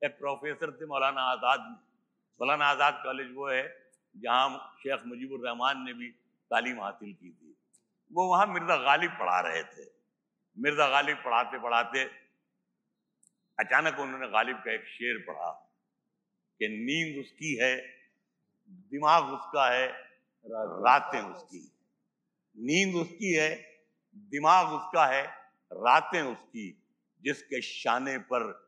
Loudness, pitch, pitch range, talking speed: -29 LUFS, 150 Hz, 130-200 Hz, 120 wpm